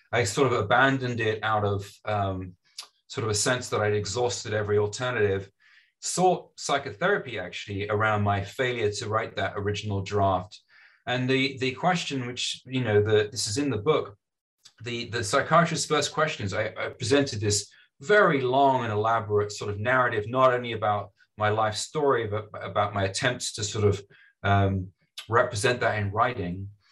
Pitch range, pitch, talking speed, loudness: 105-130 Hz, 110 Hz, 165 wpm, -26 LUFS